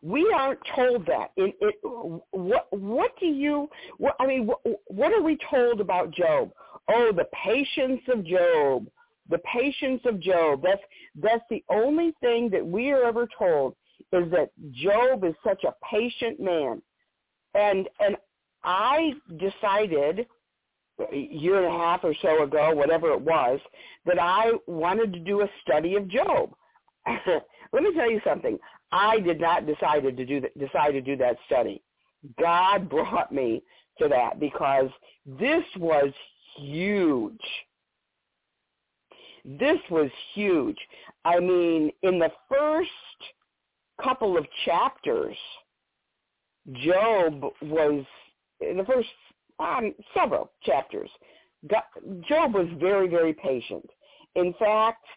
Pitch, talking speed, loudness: 215 Hz, 135 wpm, -25 LUFS